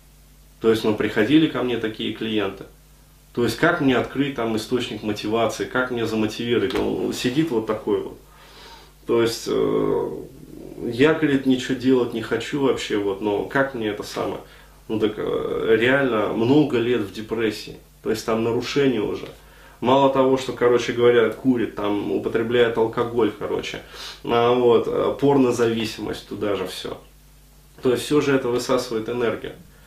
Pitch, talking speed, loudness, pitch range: 120 Hz, 150 wpm, -22 LUFS, 110-135 Hz